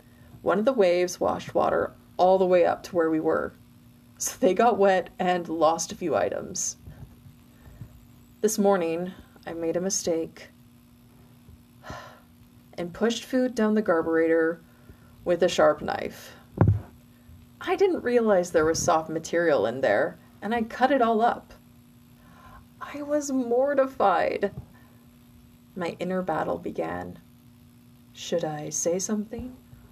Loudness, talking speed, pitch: -25 LUFS, 130 wpm, 175 Hz